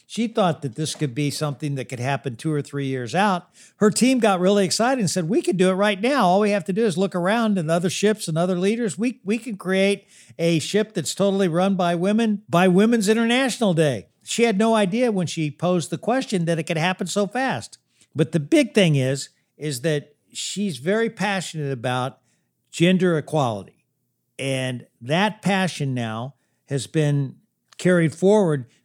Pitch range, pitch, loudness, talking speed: 150-210 Hz, 185 Hz, -22 LUFS, 195 wpm